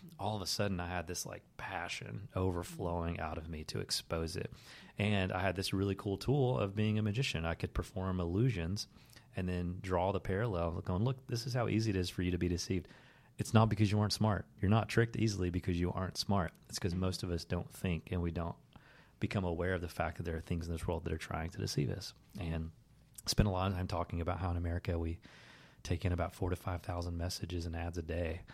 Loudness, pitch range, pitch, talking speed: -37 LUFS, 85-105 Hz, 95 Hz, 245 wpm